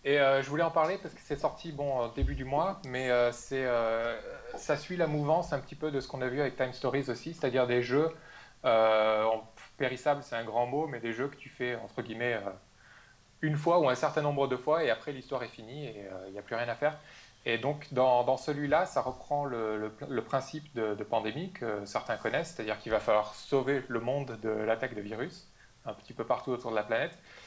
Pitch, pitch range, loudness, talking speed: 130 Hz, 115-145 Hz, -32 LUFS, 240 wpm